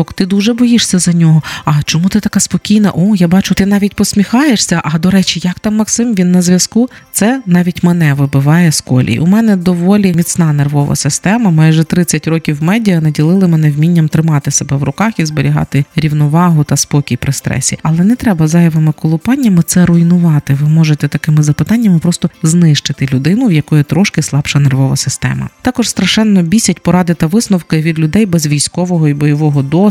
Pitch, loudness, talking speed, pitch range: 170 Hz, -10 LUFS, 175 wpm, 150-195 Hz